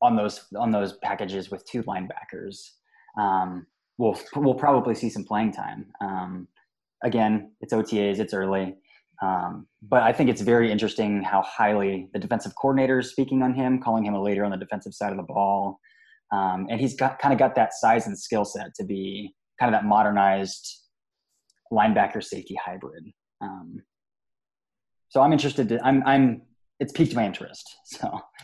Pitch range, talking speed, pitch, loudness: 100-135 Hz, 175 wpm, 115 Hz, -24 LUFS